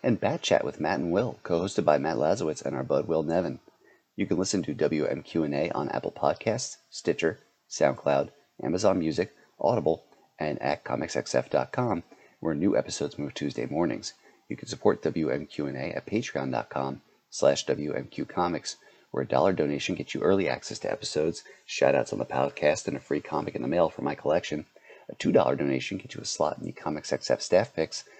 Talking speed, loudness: 185 wpm, -28 LUFS